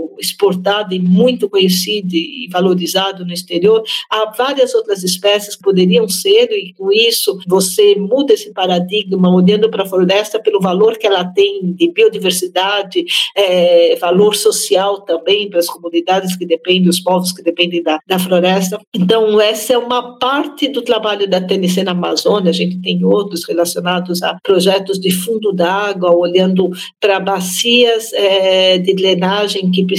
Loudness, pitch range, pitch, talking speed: -13 LUFS, 180-215 Hz, 195 Hz, 155 wpm